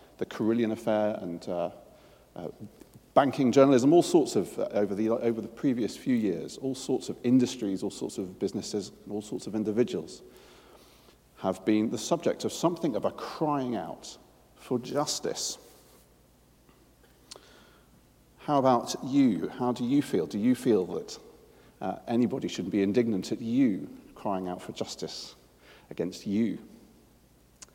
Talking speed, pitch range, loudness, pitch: 150 wpm, 105-150 Hz, -29 LUFS, 120 Hz